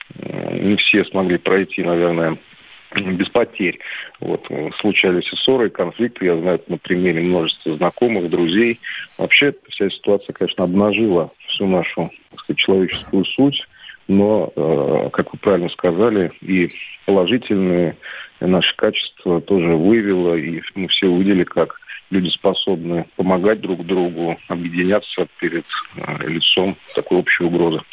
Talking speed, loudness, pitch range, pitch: 120 wpm, -18 LUFS, 85-100 Hz, 95 Hz